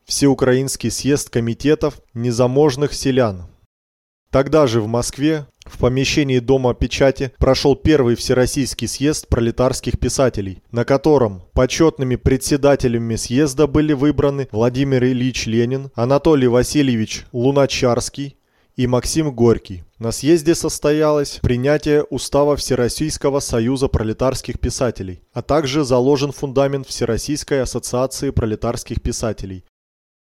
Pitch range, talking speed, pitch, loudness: 115-140 Hz, 105 wpm, 130 Hz, -18 LUFS